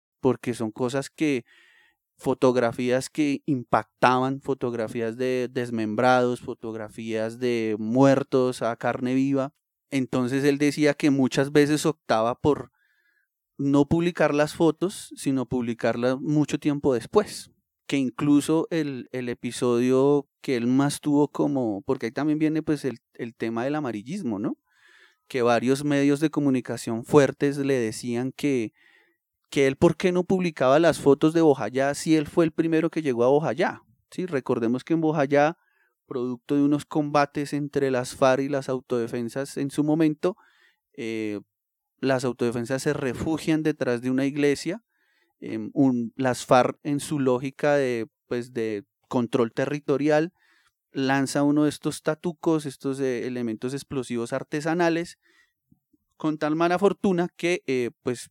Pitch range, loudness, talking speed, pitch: 125-150 Hz, -25 LUFS, 140 wpm, 135 Hz